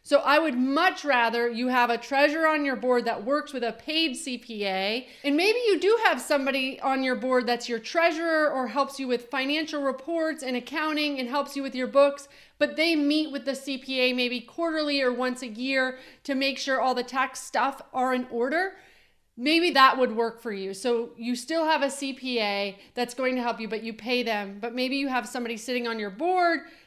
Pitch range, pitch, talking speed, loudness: 245-295 Hz, 265 Hz, 215 wpm, -26 LUFS